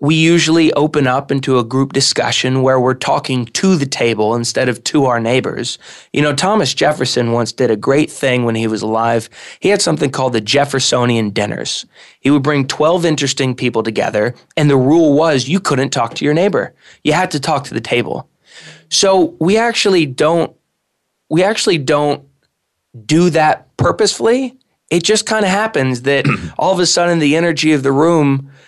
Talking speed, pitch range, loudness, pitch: 185 wpm, 130-165 Hz, -14 LUFS, 145 Hz